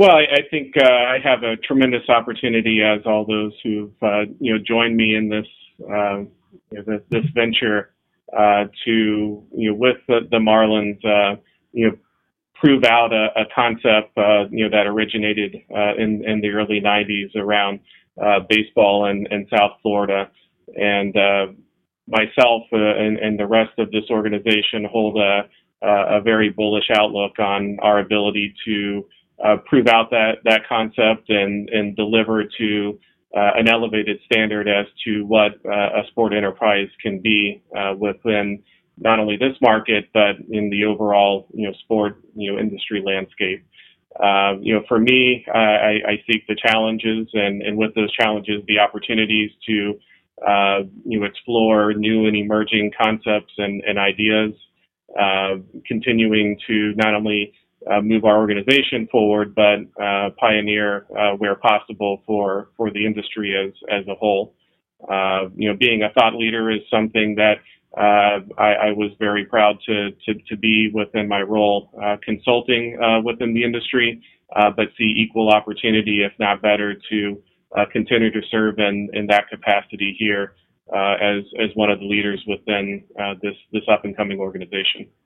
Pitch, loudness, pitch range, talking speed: 105 Hz, -18 LUFS, 100-110 Hz, 165 wpm